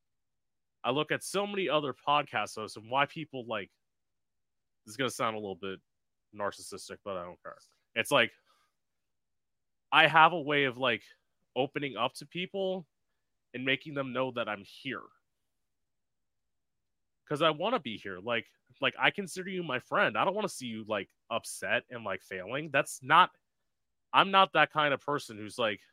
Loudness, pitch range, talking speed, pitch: -30 LUFS, 115-160 Hz, 180 wpm, 140 Hz